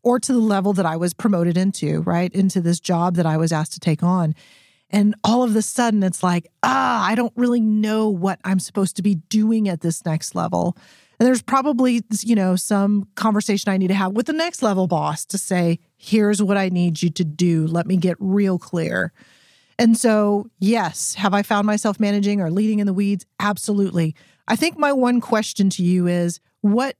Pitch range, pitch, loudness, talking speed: 175-215 Hz, 200 Hz, -20 LUFS, 210 wpm